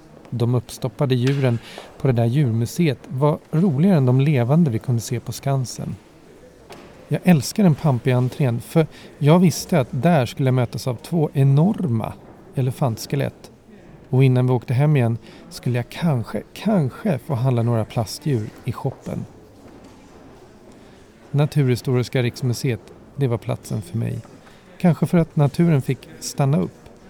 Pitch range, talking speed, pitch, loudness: 120-155 Hz, 140 wpm, 135 Hz, -21 LUFS